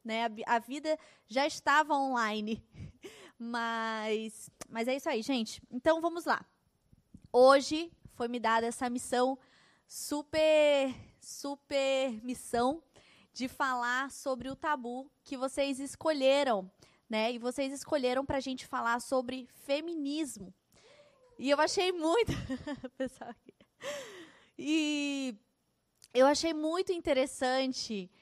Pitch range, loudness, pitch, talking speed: 245-295 Hz, -32 LUFS, 265 Hz, 105 wpm